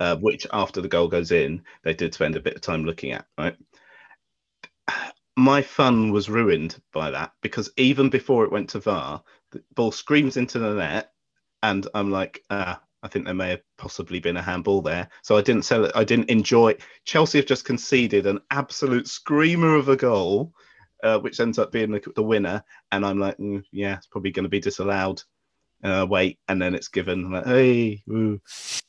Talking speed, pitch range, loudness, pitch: 210 wpm, 100-130 Hz, -23 LUFS, 105 Hz